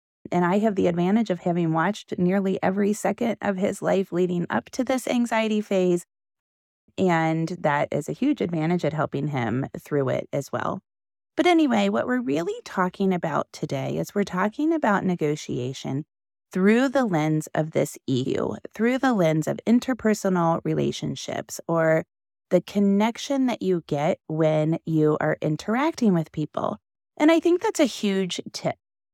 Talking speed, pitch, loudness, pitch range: 160 wpm, 185 Hz, -24 LUFS, 160-220 Hz